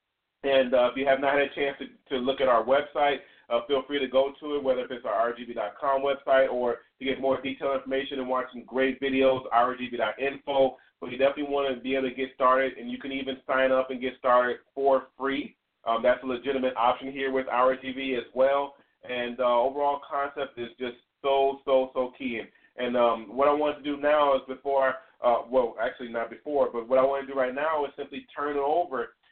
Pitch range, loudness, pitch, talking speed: 125-140 Hz, -27 LUFS, 135 Hz, 225 wpm